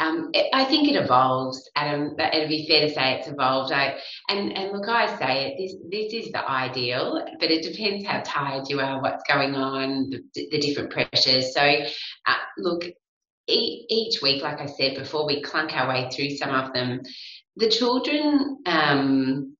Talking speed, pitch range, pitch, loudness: 190 wpm, 135-195 Hz, 145 Hz, -23 LUFS